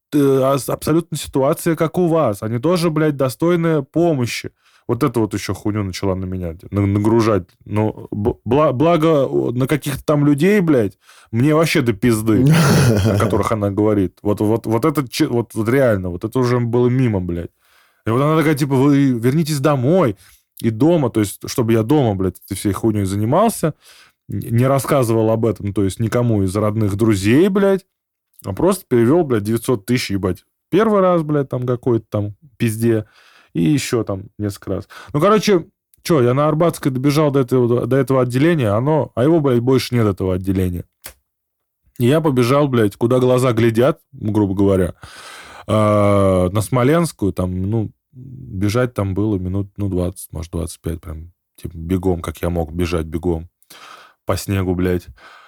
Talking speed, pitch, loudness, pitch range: 160 wpm, 120 Hz, -17 LUFS, 100-145 Hz